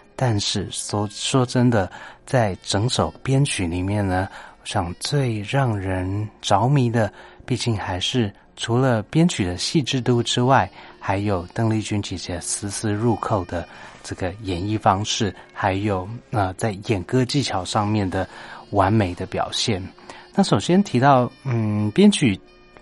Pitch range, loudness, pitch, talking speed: 95-125 Hz, -22 LUFS, 110 Hz, 210 characters per minute